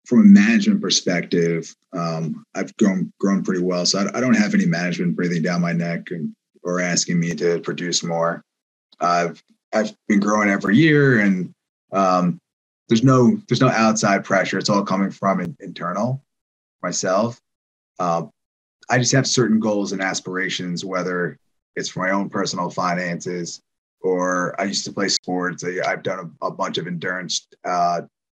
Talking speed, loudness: 165 wpm, -20 LUFS